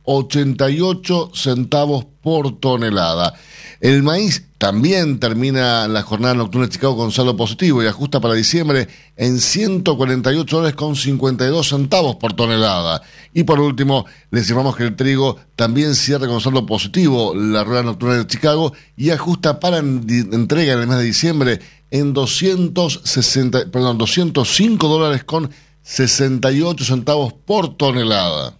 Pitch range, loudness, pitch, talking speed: 120-155 Hz, -16 LUFS, 135 Hz, 135 wpm